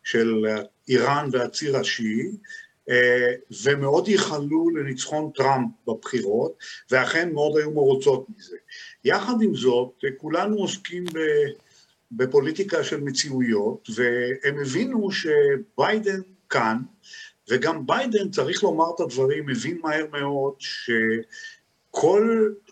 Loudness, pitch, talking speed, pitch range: -23 LUFS, 160 Hz, 95 wpm, 130-215 Hz